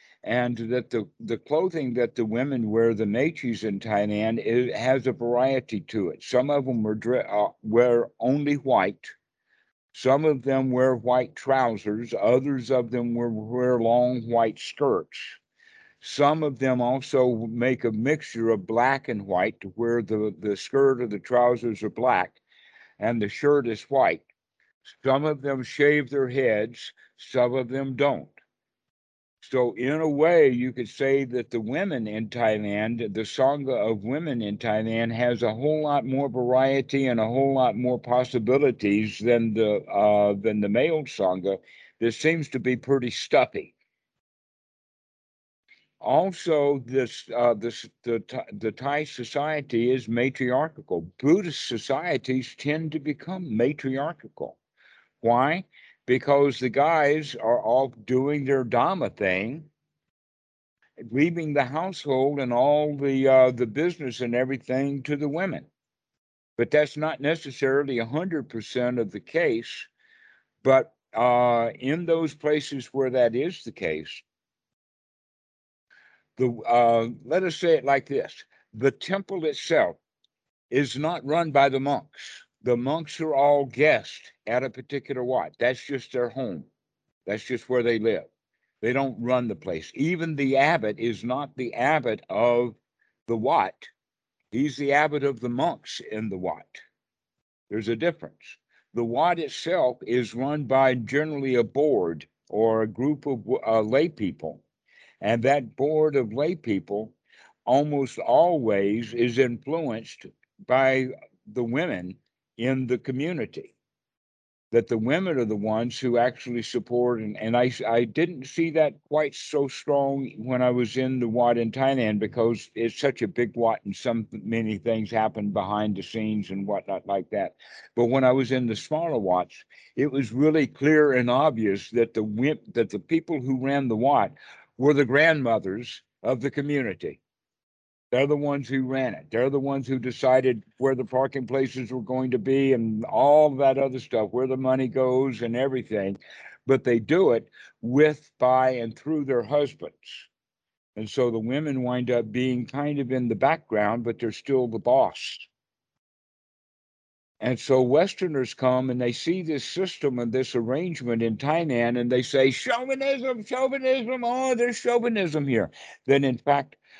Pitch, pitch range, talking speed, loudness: 130 Hz, 115-140 Hz, 155 wpm, -25 LUFS